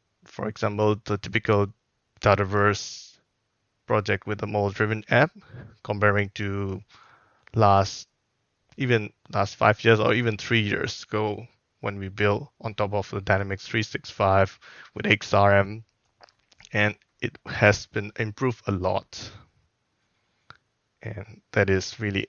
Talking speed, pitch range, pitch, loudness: 120 wpm, 100-110 Hz, 105 Hz, -25 LUFS